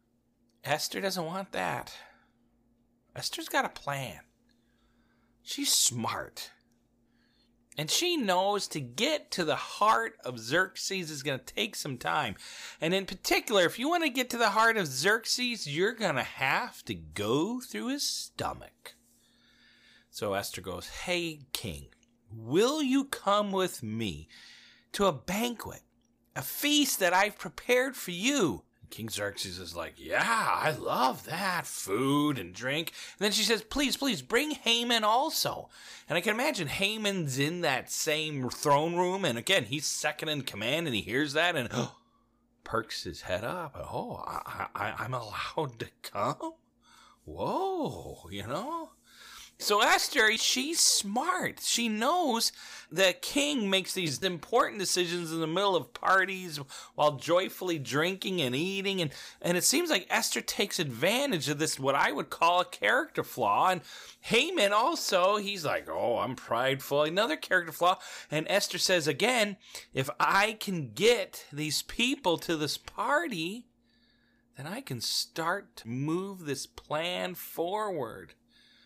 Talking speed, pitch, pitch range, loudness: 150 wpm, 180 Hz, 140-220 Hz, -29 LUFS